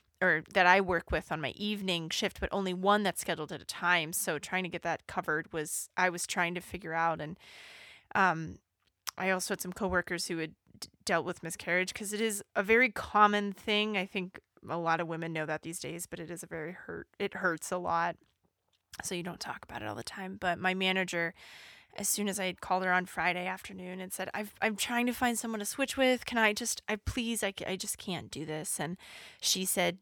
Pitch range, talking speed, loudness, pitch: 170-205 Hz, 230 wpm, -32 LUFS, 185 Hz